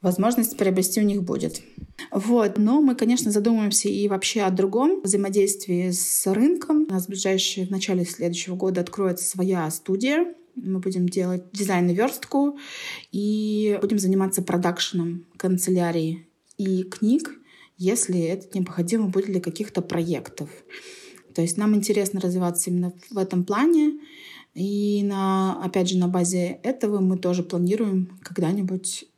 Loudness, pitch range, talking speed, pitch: -23 LUFS, 180-215 Hz, 140 wpm, 195 Hz